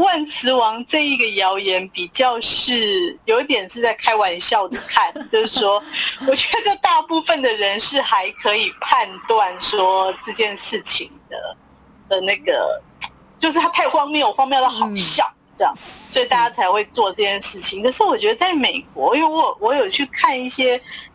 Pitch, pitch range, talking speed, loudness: 255 Hz, 205-335 Hz, 245 characters per minute, -17 LUFS